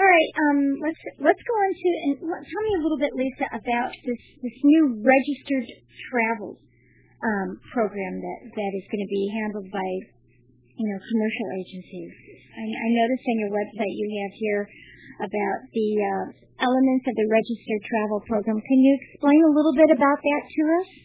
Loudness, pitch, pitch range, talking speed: -23 LUFS, 230 Hz, 205-285 Hz, 180 wpm